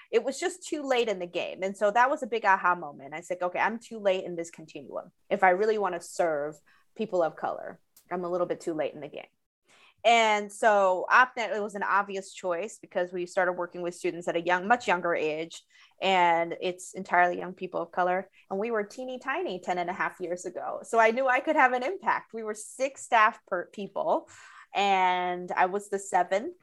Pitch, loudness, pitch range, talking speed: 190 Hz, -28 LUFS, 175-220 Hz, 230 wpm